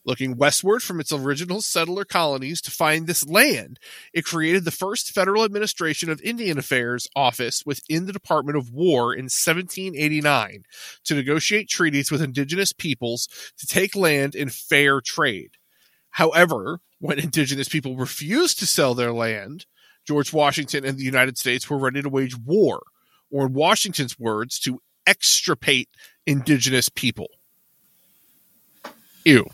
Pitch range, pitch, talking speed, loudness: 135-175 Hz, 150 Hz, 140 wpm, -21 LUFS